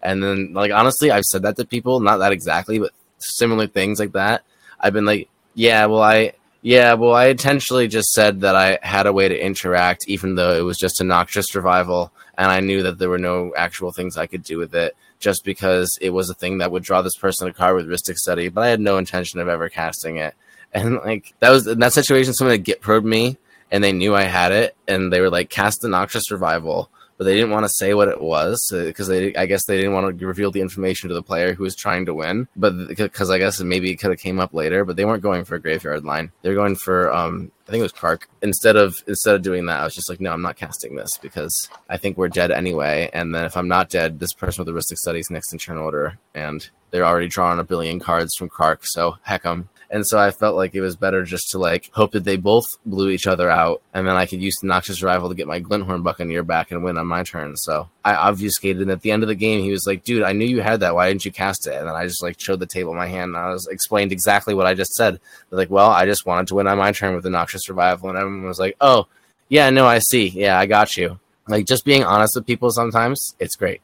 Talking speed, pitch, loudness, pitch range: 270 wpm, 95 Hz, -18 LUFS, 90-105 Hz